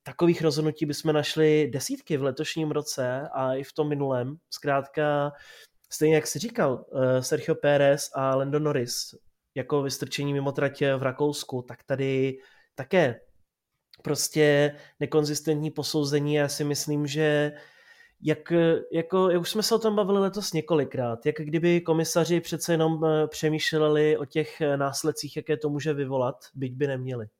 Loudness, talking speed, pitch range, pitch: -26 LUFS, 140 wpm, 140-155 Hz, 150 Hz